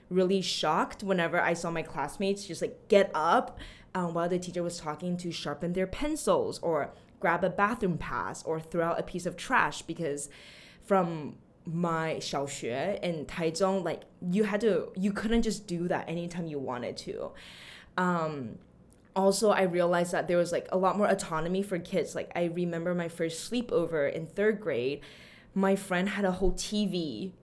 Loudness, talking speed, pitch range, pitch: -30 LUFS, 175 wpm, 165-195 Hz, 180 Hz